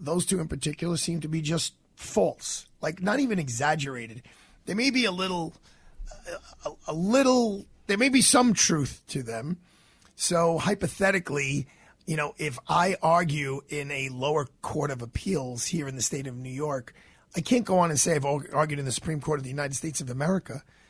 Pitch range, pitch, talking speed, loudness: 140-175 Hz, 155 Hz, 190 wpm, -27 LUFS